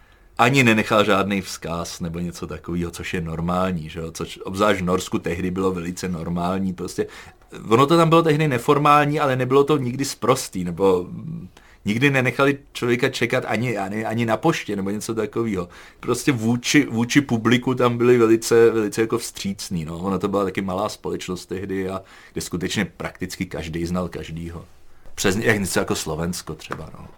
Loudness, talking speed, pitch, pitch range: -21 LUFS, 170 wpm, 100 Hz, 90-120 Hz